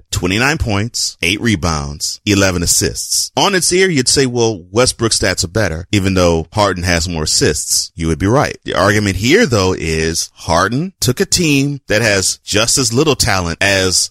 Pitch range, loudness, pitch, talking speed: 90-120 Hz, -13 LUFS, 100 Hz, 180 wpm